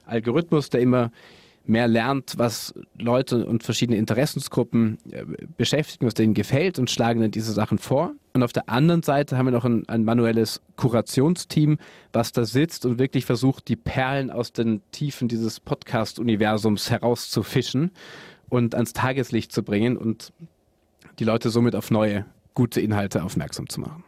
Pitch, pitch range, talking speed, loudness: 120 Hz, 110-135 Hz, 155 wpm, -23 LUFS